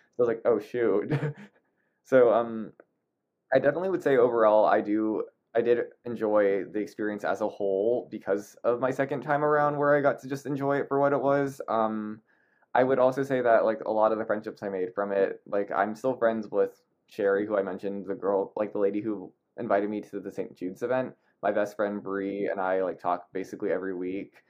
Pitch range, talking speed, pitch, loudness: 100-130 Hz, 215 wpm, 110 Hz, -27 LUFS